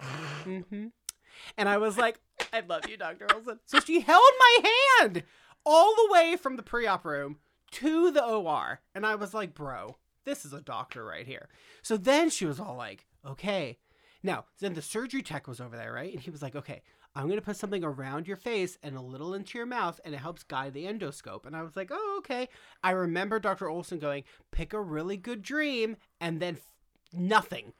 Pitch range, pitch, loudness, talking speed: 155-240 Hz, 195 Hz, -27 LUFS, 210 wpm